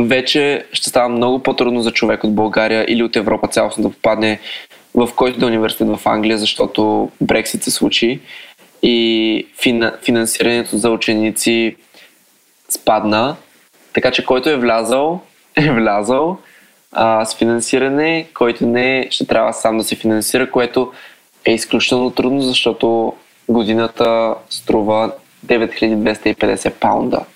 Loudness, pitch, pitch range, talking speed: -15 LUFS, 115 Hz, 110-125 Hz, 125 wpm